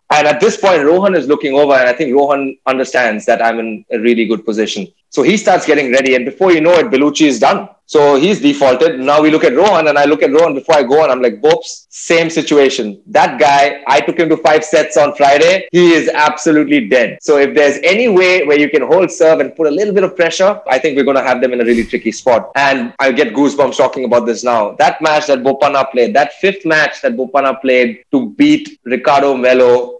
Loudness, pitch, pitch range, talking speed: -11 LUFS, 145 Hz, 130-160 Hz, 240 wpm